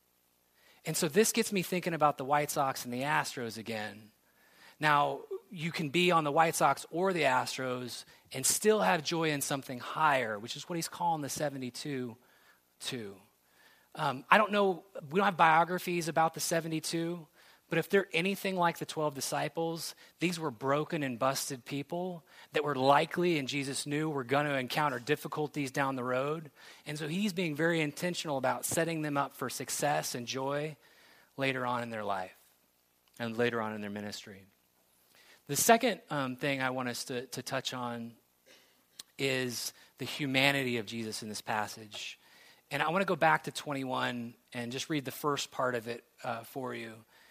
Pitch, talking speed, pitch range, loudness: 145 Hz, 180 wpm, 125-165 Hz, -32 LUFS